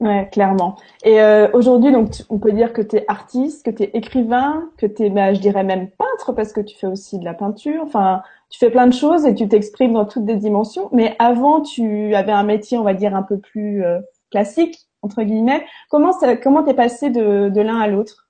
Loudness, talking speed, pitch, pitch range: -16 LUFS, 240 wpm, 220 Hz, 205-255 Hz